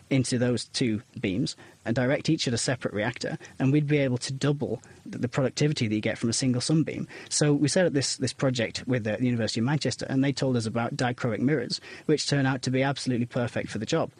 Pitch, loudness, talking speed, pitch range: 130 Hz, -27 LUFS, 235 wpm, 120-140 Hz